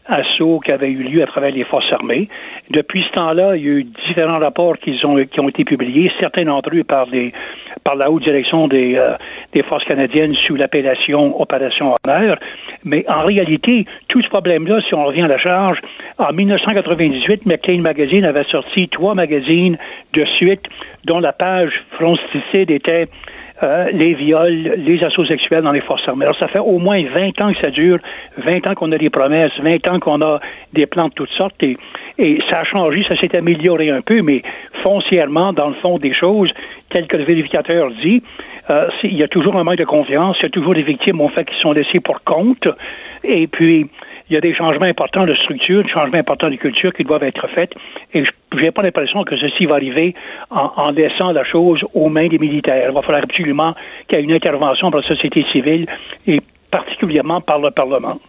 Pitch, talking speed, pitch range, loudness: 165 Hz, 210 wpm, 150-185 Hz, -14 LUFS